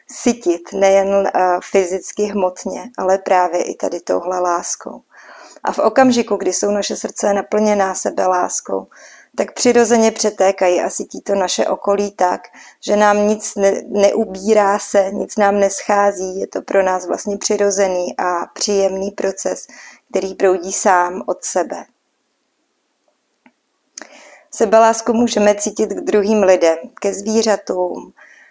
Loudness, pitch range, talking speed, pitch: -16 LUFS, 185-210 Hz, 125 wpm, 200 Hz